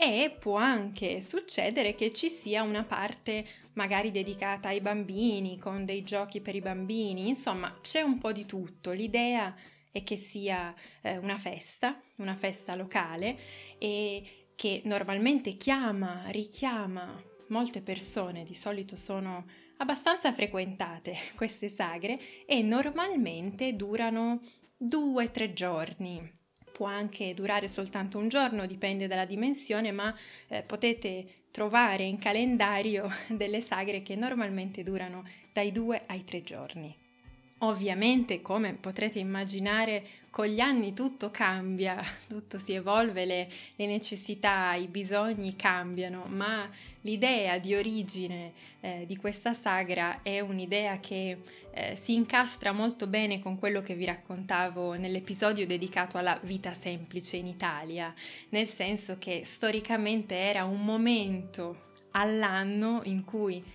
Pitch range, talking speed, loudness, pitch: 190-220 Hz, 125 wpm, -32 LUFS, 200 Hz